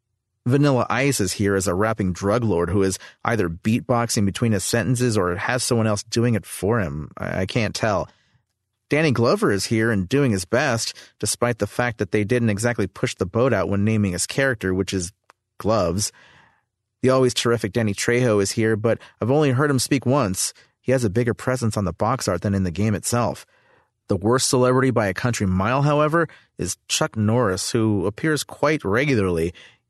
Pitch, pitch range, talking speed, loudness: 115 Hz, 100-125 Hz, 195 wpm, -21 LUFS